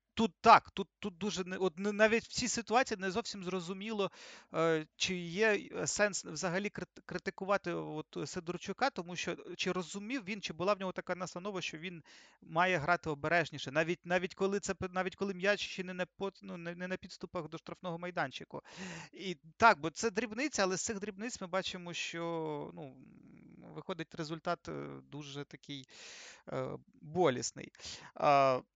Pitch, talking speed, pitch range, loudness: 185 Hz, 160 wpm, 170-200 Hz, -35 LUFS